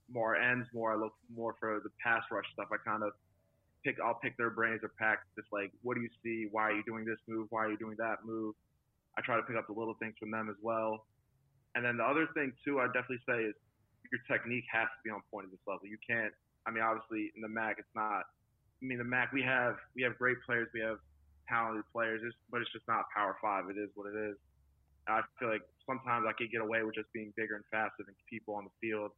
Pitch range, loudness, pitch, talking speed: 105-115 Hz, -37 LUFS, 110 Hz, 255 wpm